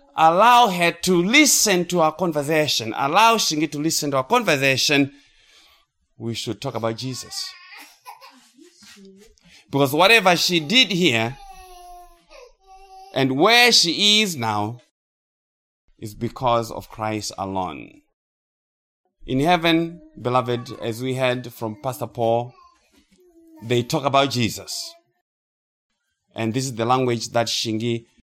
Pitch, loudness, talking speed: 140 Hz, -19 LUFS, 115 wpm